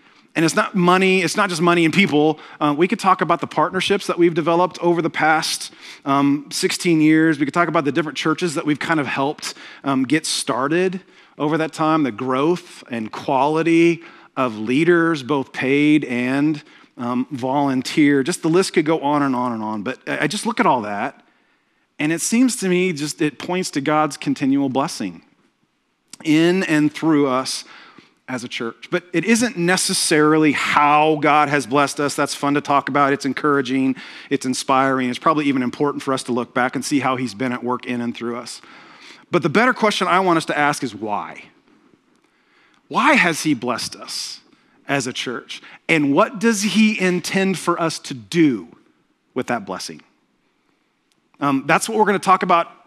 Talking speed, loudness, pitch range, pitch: 190 wpm, -19 LUFS, 140-180 Hz, 155 Hz